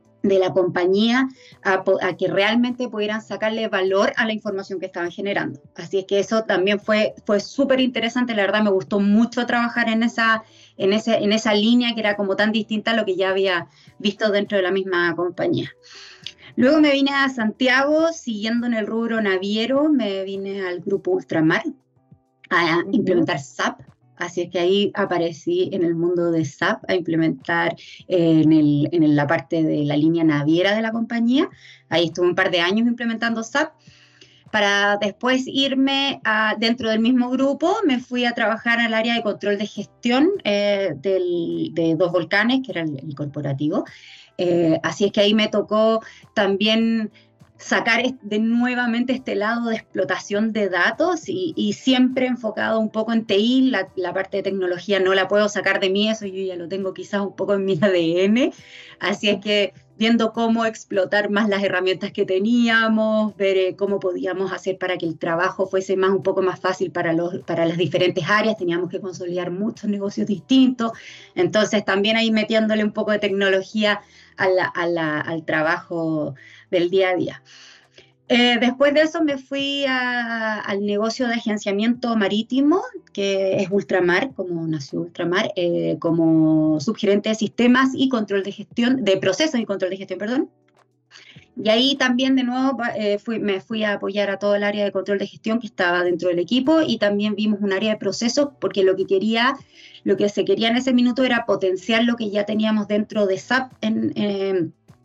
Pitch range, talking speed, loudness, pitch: 185-230 Hz, 185 wpm, -20 LUFS, 205 Hz